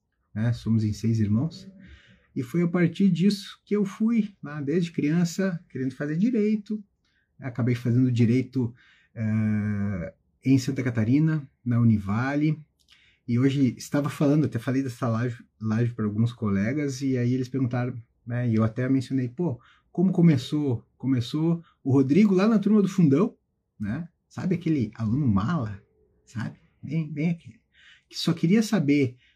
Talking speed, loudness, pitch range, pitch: 150 wpm, -25 LUFS, 120-170 Hz, 135 Hz